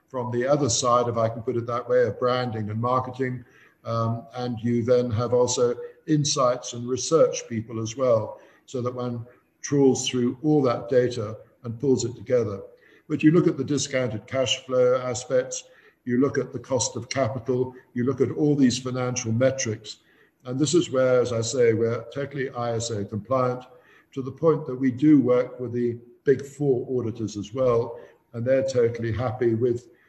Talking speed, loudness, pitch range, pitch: 185 wpm, -24 LUFS, 120-135 Hz, 125 Hz